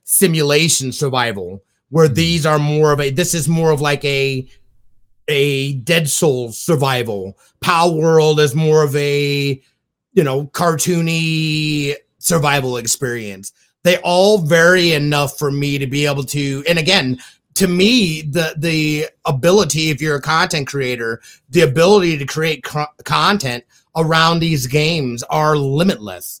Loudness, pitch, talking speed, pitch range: -15 LUFS, 150 Hz, 140 wpm, 135-165 Hz